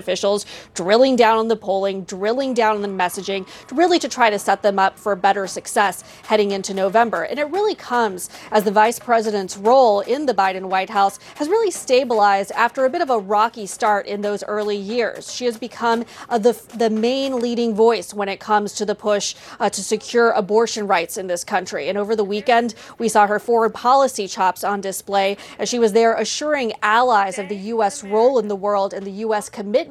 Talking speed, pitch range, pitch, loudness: 210 wpm, 200-235 Hz, 215 Hz, -19 LUFS